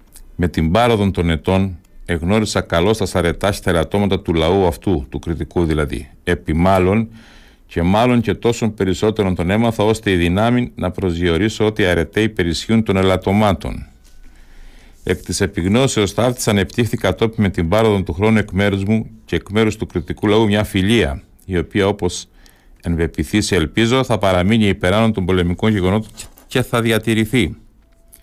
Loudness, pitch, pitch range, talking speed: -17 LUFS, 95 Hz, 90-110 Hz, 155 wpm